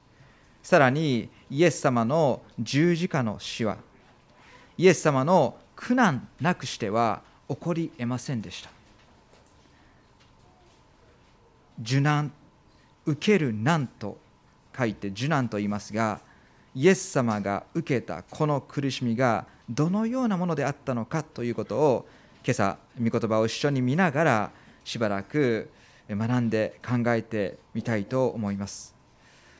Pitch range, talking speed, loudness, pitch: 110-155 Hz, 240 characters per minute, -26 LUFS, 125 Hz